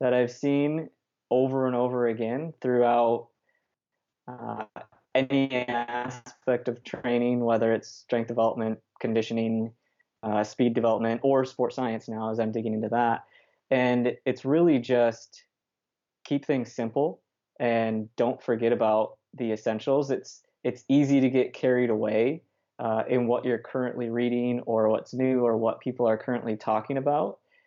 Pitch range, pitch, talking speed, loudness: 115-130 Hz, 120 Hz, 145 wpm, -27 LUFS